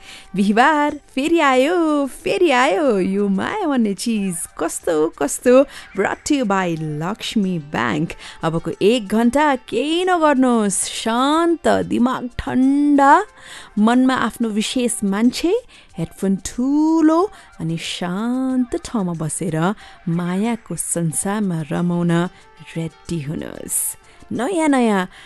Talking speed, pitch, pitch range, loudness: 95 wpm, 225 Hz, 180-275 Hz, -18 LUFS